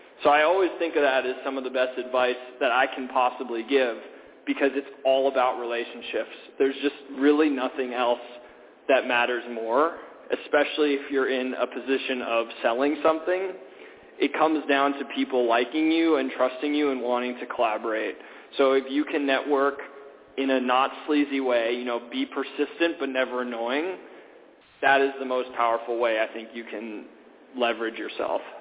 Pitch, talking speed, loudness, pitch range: 135 Hz, 170 wpm, -25 LUFS, 125-140 Hz